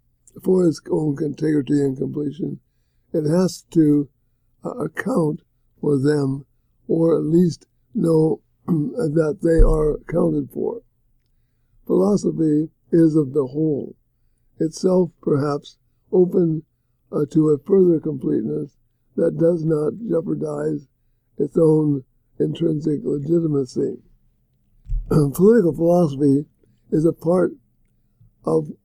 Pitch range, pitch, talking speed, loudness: 125-165 Hz, 150 Hz, 100 wpm, -20 LUFS